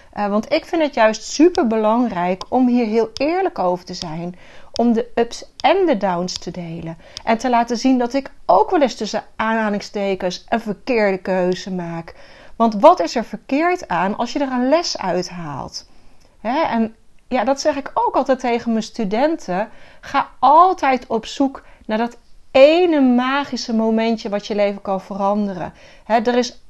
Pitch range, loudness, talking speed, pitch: 205-270 Hz, -18 LUFS, 175 wpm, 230 Hz